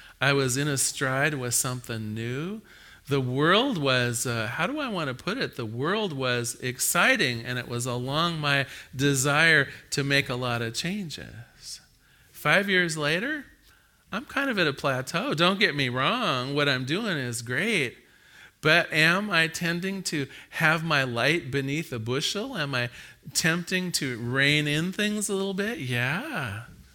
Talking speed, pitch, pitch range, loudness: 165 wpm, 145 Hz, 125-175 Hz, -25 LUFS